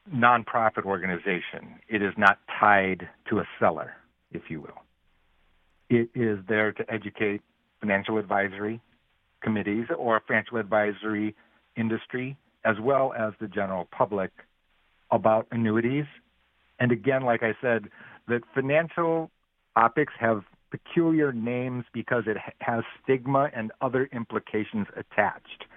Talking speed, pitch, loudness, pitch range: 120 wpm, 115 Hz, -27 LUFS, 105-125 Hz